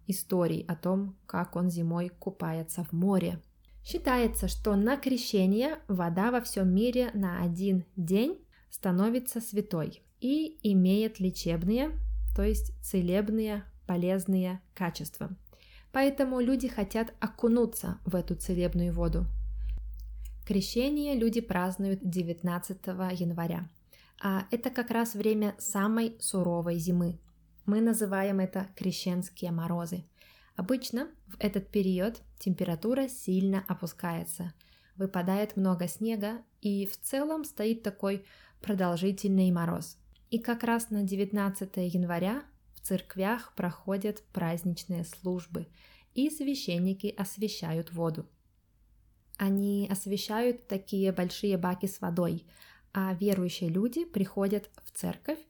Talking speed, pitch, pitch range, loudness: 110 wpm, 195 Hz, 180-220 Hz, -31 LUFS